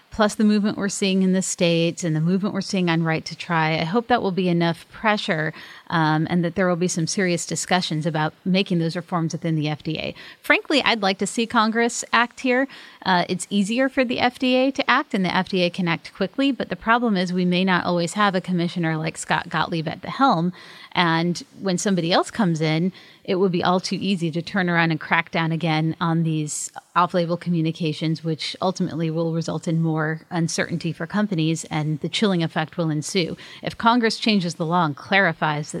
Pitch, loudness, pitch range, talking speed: 175 Hz, -22 LUFS, 165-200 Hz, 210 wpm